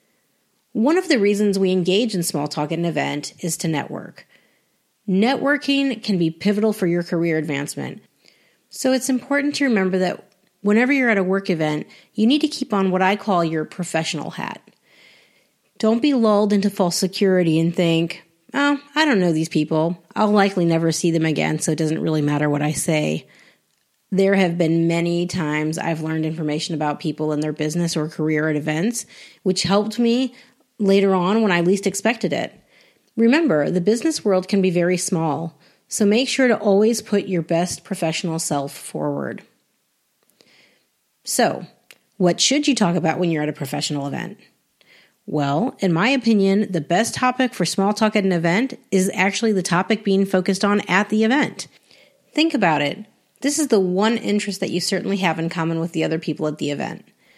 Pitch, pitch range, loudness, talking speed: 185 Hz, 165-215 Hz, -20 LUFS, 185 wpm